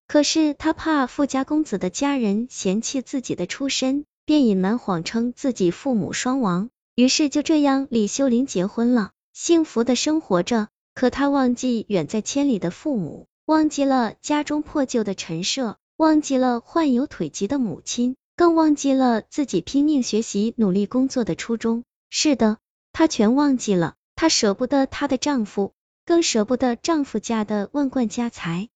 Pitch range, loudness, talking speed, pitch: 215-285 Hz, -21 LUFS, 250 characters per minute, 255 Hz